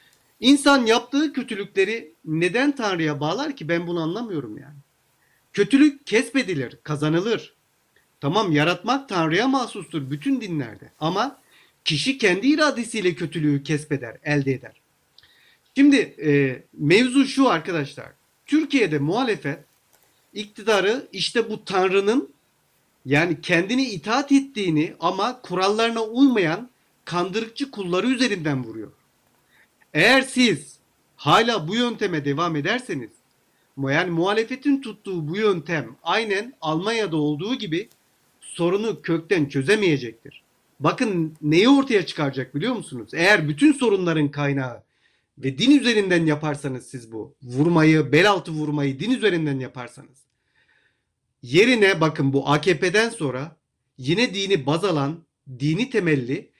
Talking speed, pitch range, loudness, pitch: 110 wpm, 150-225 Hz, -21 LUFS, 175 Hz